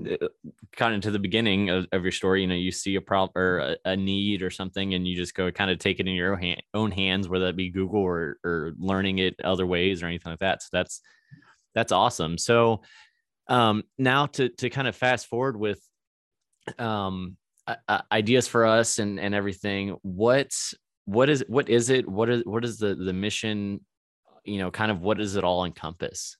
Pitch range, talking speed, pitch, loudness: 95-115 Hz, 210 wpm, 100 Hz, -26 LUFS